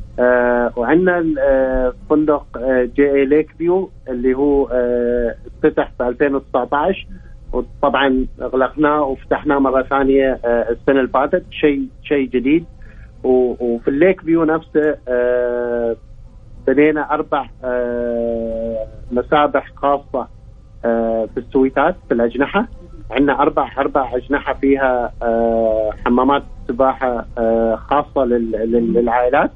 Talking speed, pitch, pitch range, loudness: 100 wpm, 130 Hz, 120-140 Hz, -17 LUFS